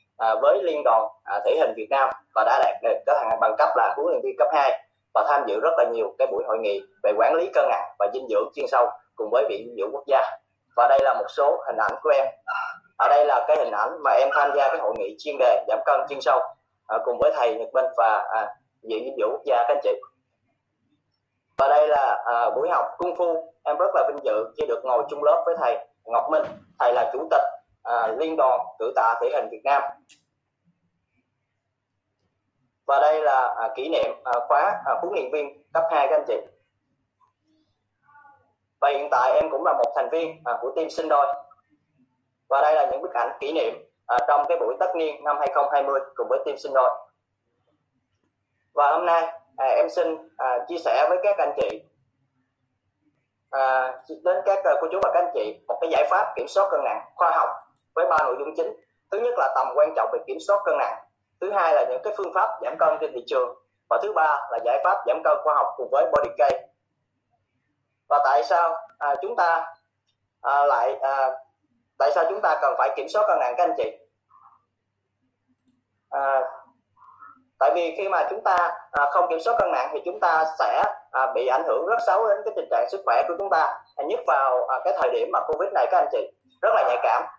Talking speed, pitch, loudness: 220 wpm, 160 Hz, -23 LUFS